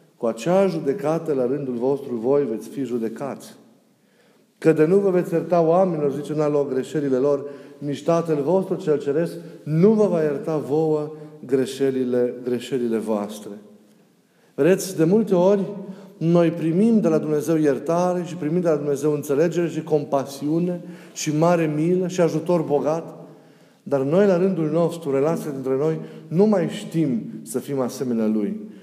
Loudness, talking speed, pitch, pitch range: -21 LUFS, 155 wpm, 155 Hz, 140-175 Hz